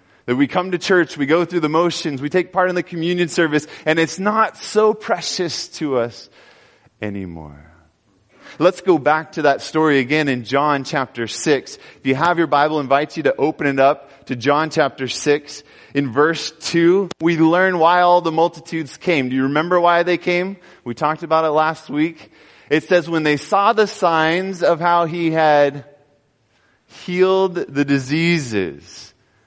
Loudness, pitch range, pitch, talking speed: -18 LUFS, 140-175 Hz, 155 Hz, 180 wpm